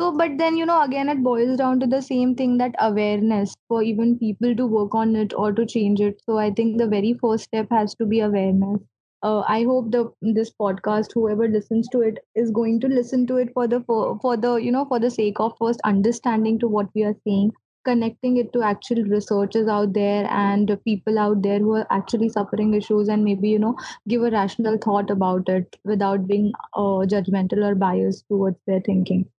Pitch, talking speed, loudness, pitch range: 220 Hz, 215 wpm, -21 LUFS, 205-235 Hz